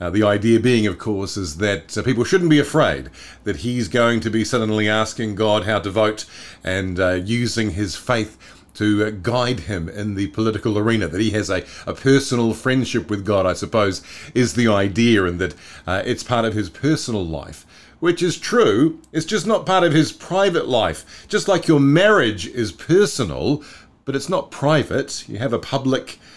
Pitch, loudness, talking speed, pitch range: 110 Hz, -19 LUFS, 195 wpm, 100-130 Hz